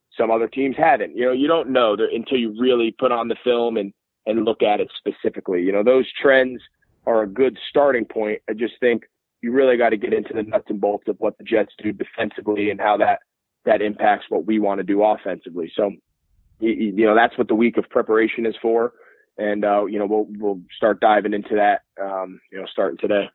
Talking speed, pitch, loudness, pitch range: 225 wpm, 110 Hz, -20 LUFS, 105-120 Hz